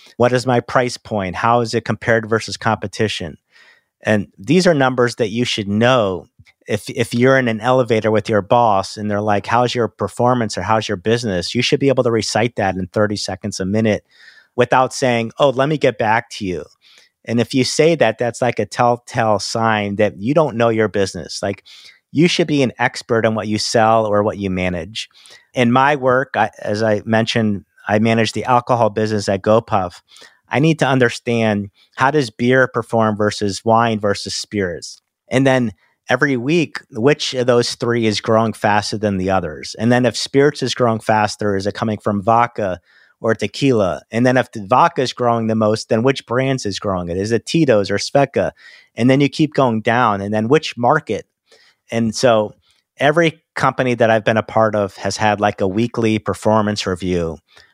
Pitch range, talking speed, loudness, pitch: 105-125 Hz, 195 wpm, -17 LUFS, 115 Hz